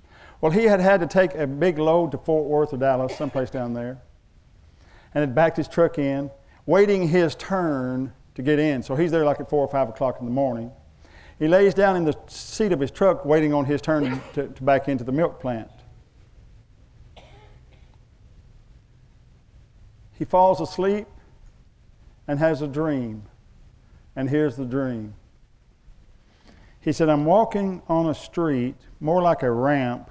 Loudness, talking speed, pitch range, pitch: -22 LUFS, 165 wpm, 125-165 Hz, 145 Hz